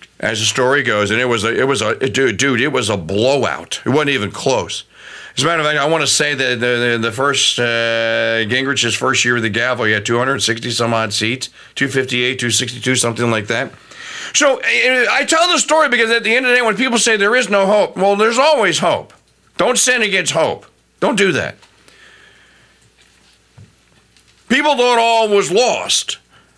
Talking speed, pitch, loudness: 200 wpm, 140 Hz, -14 LUFS